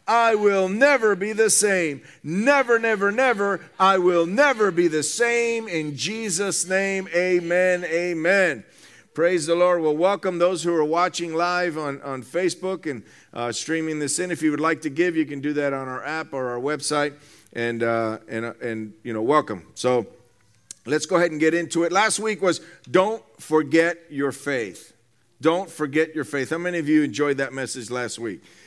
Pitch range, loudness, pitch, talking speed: 140-185 Hz, -22 LUFS, 165 Hz, 190 wpm